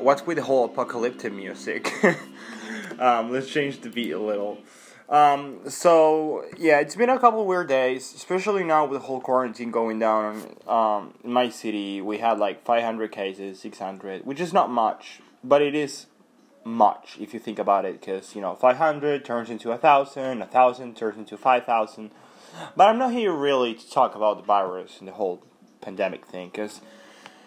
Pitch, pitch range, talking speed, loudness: 125 Hz, 110-145 Hz, 180 wpm, -23 LUFS